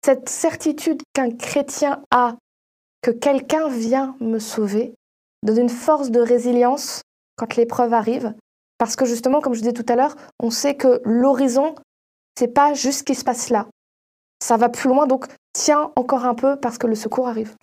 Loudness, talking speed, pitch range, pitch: -20 LUFS, 185 wpm, 235-280 Hz, 255 Hz